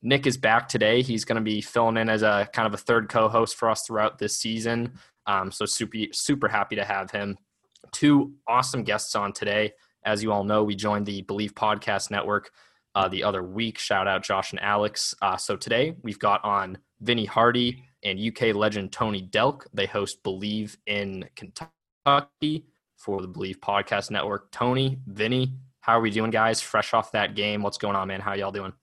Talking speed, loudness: 200 wpm, -25 LUFS